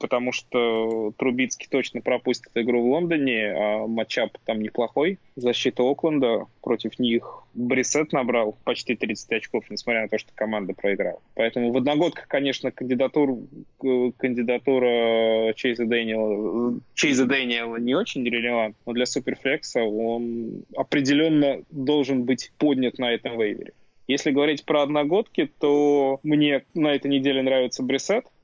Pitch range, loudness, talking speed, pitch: 115-135 Hz, -24 LUFS, 130 wpm, 125 Hz